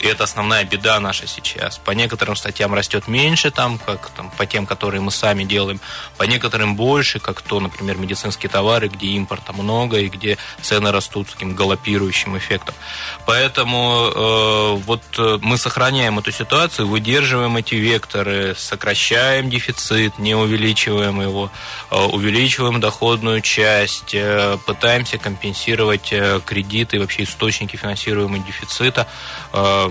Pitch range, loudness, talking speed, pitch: 100-115 Hz, -17 LUFS, 140 wpm, 105 Hz